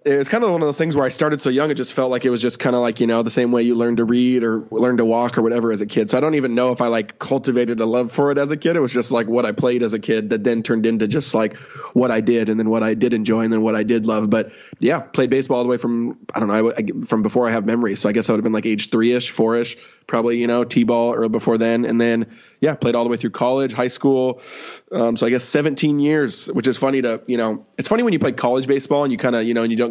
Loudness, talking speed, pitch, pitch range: -19 LUFS, 330 wpm, 120 Hz, 115-130 Hz